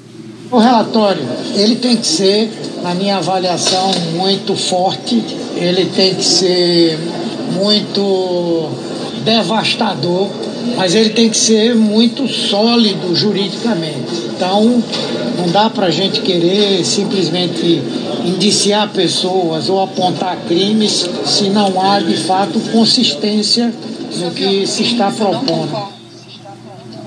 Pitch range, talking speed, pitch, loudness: 180-215 Hz, 110 wpm, 195 Hz, -13 LUFS